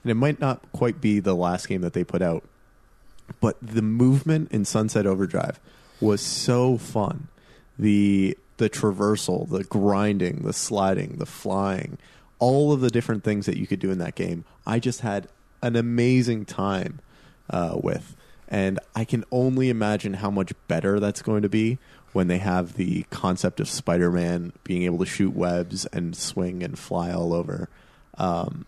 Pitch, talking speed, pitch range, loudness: 105 Hz, 175 wpm, 95-120 Hz, -25 LUFS